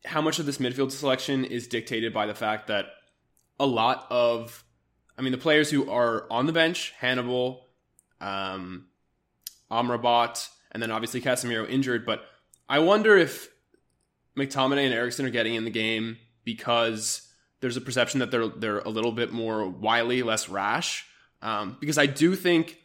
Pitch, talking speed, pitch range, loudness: 120 Hz, 165 wpm, 115-130 Hz, -26 LUFS